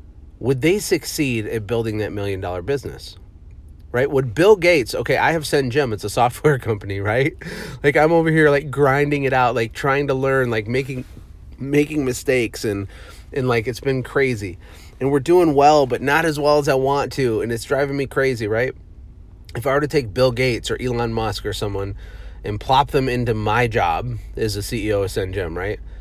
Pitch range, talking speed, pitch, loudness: 105-140 Hz, 195 wpm, 125 Hz, -19 LUFS